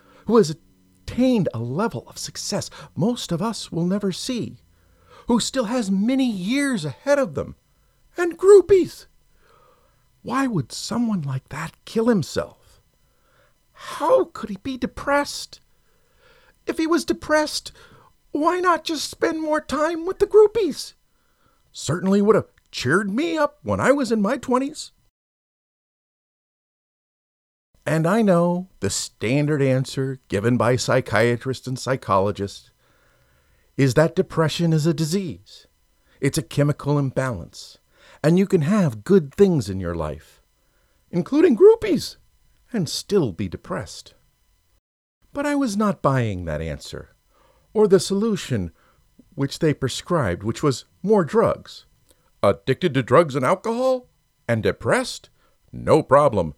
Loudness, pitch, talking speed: -21 LUFS, 175 Hz, 130 wpm